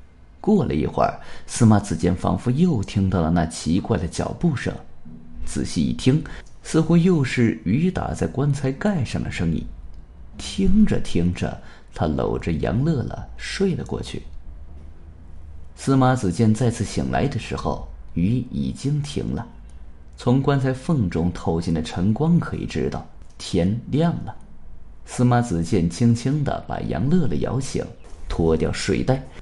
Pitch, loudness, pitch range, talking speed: 90 Hz, -22 LUFS, 80-130 Hz, 210 characters per minute